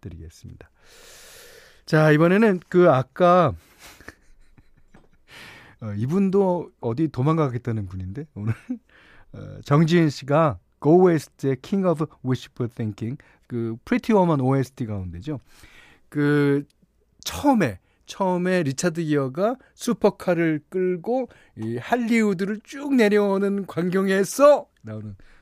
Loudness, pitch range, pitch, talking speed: -22 LUFS, 125-195 Hz, 160 Hz, 285 characters per minute